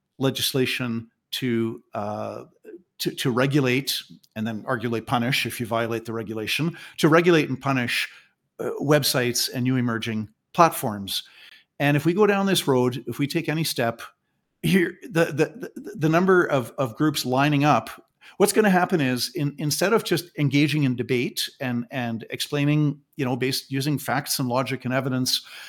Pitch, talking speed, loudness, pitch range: 135 Hz, 170 wpm, -23 LUFS, 120-150 Hz